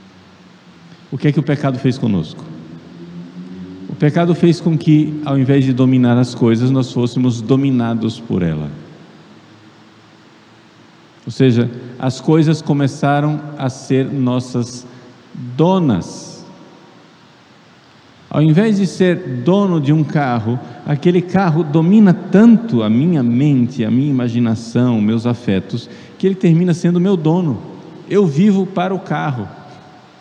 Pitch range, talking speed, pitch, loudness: 120-165 Hz, 125 wpm, 135 Hz, -15 LUFS